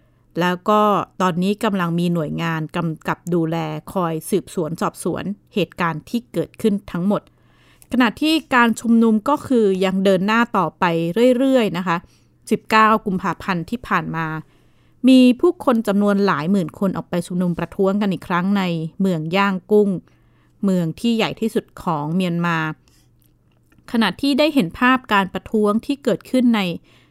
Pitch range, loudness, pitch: 175-225 Hz, -19 LUFS, 195 Hz